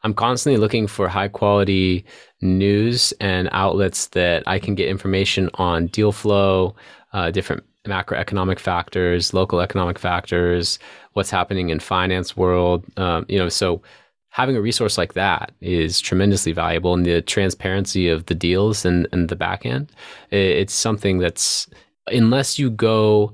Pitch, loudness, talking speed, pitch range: 95 Hz, -19 LUFS, 150 wpm, 90-100 Hz